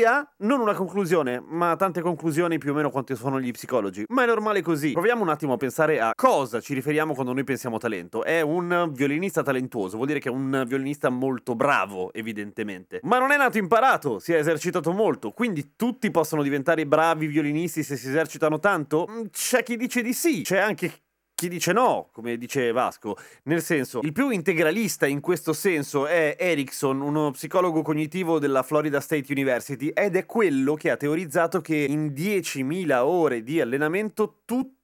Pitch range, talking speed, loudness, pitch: 140-190 Hz, 180 wpm, -24 LUFS, 155 Hz